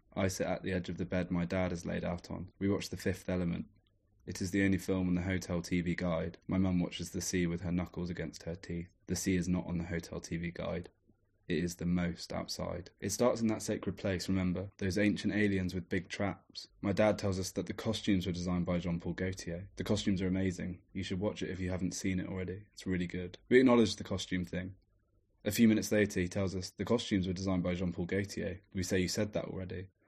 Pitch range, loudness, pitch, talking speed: 90-100 Hz, -35 LUFS, 95 Hz, 240 wpm